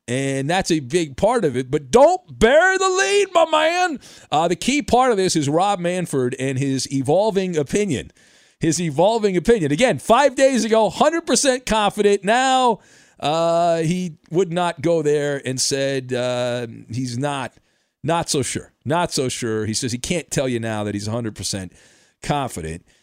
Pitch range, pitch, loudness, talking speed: 130-210 Hz, 165 Hz, -19 LUFS, 170 wpm